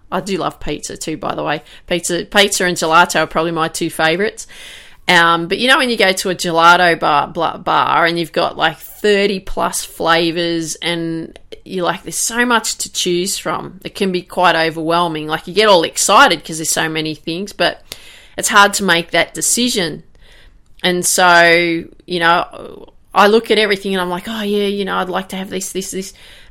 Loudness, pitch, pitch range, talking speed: -14 LUFS, 180 Hz, 165-200 Hz, 205 wpm